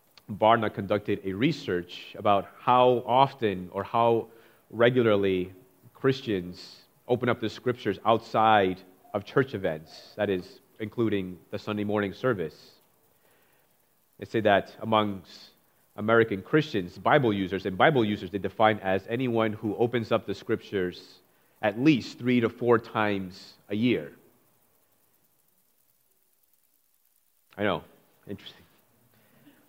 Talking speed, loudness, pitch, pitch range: 115 wpm, -27 LUFS, 110 Hz, 100-120 Hz